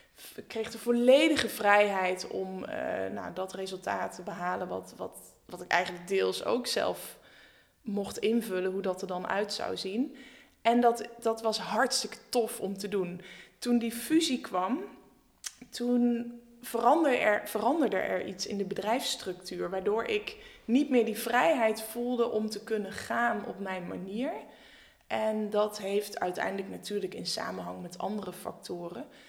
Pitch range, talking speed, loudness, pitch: 190-240 Hz, 155 wpm, -30 LUFS, 220 Hz